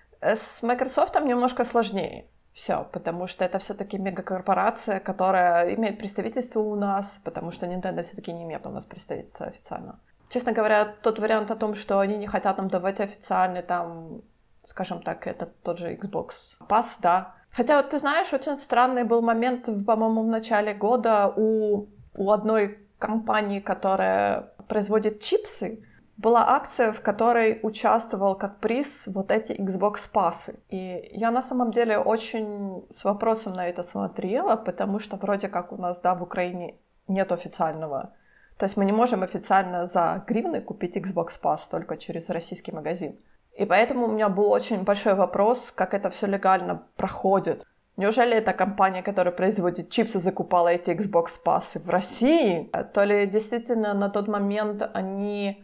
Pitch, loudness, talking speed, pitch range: 205 Hz, -25 LUFS, 155 wpm, 185-225 Hz